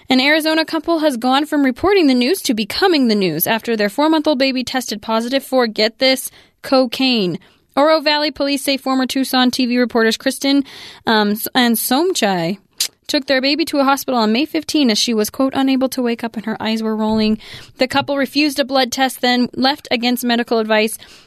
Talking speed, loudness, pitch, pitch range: 200 wpm, -16 LUFS, 260 Hz, 225-280 Hz